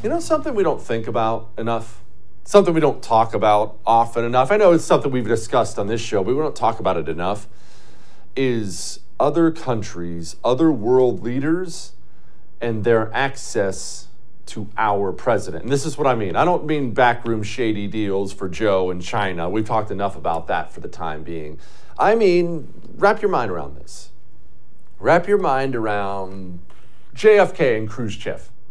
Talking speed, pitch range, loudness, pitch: 170 wpm, 100-140 Hz, -20 LUFS, 115 Hz